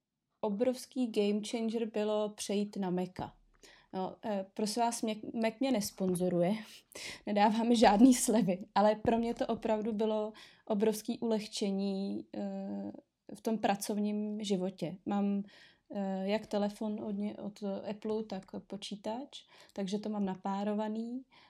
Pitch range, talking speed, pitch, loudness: 200-225 Hz, 110 wpm, 210 Hz, -34 LUFS